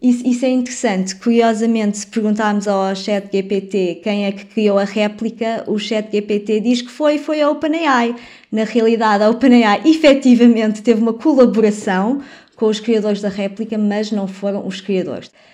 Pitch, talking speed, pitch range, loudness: 220 Hz, 165 wpm, 205-245 Hz, -16 LUFS